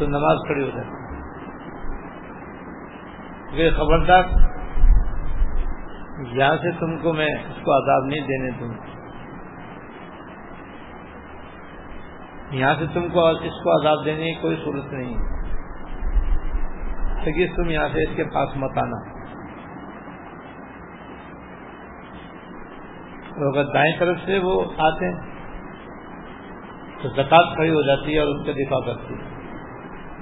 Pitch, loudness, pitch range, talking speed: 150 Hz, -22 LUFS, 135-165 Hz, 110 wpm